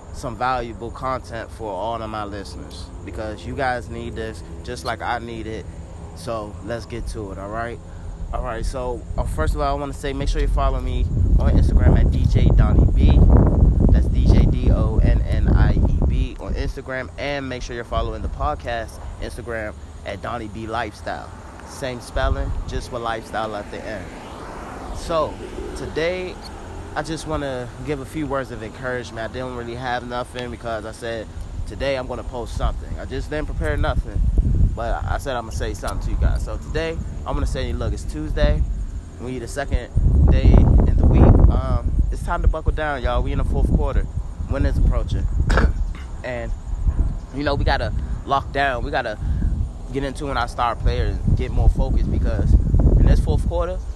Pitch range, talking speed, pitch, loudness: 80-120 Hz, 195 wpm, 100 Hz, -22 LUFS